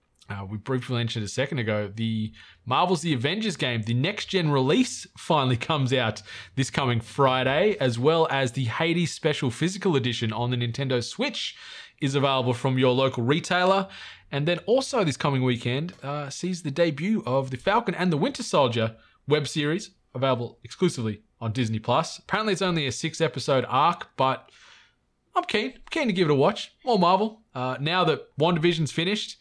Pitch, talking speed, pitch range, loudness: 140 Hz, 175 wpm, 125-180 Hz, -25 LUFS